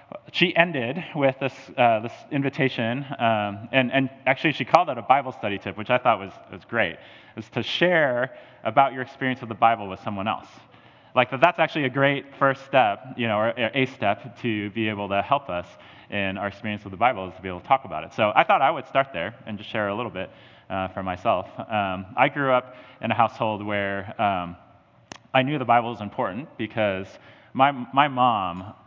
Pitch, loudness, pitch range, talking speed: 120 Hz, -24 LUFS, 100-135 Hz, 215 wpm